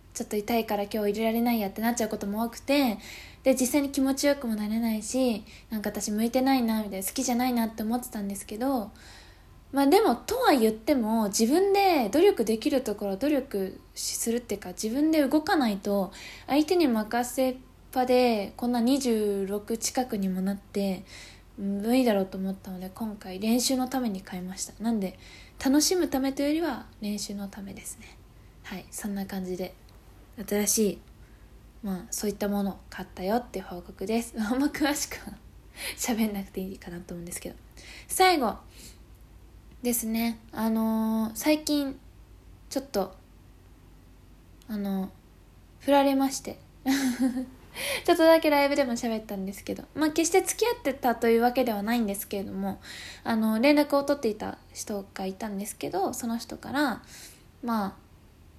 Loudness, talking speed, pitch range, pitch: -27 LUFS, 340 characters per minute, 200-265 Hz, 225 Hz